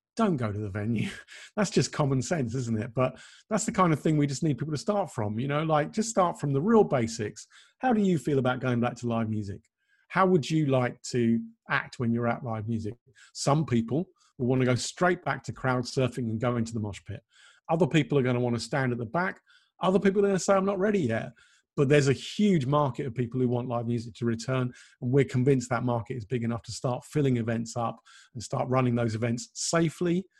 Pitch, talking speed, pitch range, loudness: 130 Hz, 245 wpm, 120-165 Hz, -28 LUFS